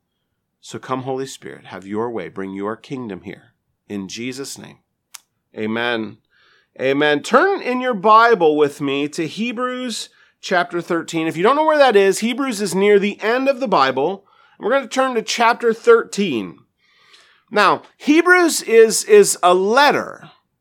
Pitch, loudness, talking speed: 200 Hz, -17 LUFS, 155 wpm